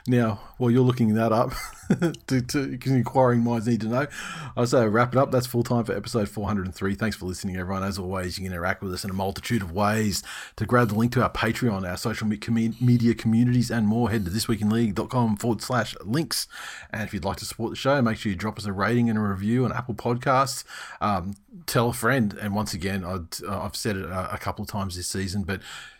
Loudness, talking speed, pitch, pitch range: -25 LUFS, 240 wpm, 110 Hz, 100-120 Hz